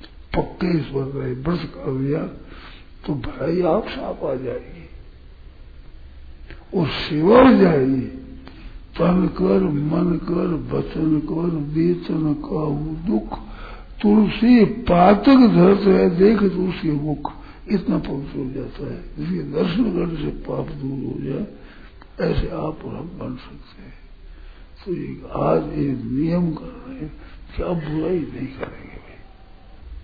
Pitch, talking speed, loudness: 155 Hz, 105 wpm, -20 LUFS